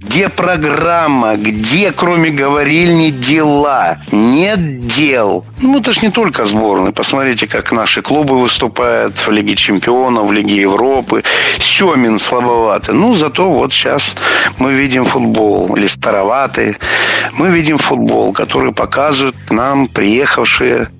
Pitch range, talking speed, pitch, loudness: 120-165 Hz, 125 wpm, 140 Hz, -11 LUFS